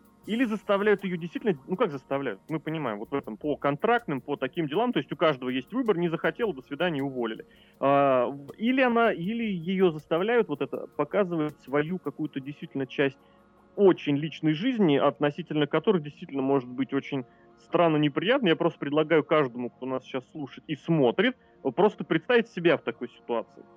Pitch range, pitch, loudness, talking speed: 140-185 Hz, 155 Hz, -27 LUFS, 170 wpm